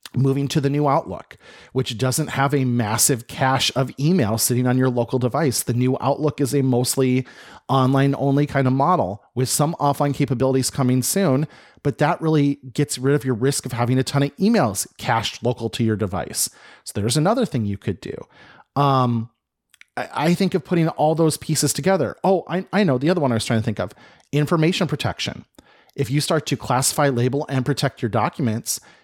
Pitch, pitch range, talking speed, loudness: 135 Hz, 125-150 Hz, 195 wpm, -20 LUFS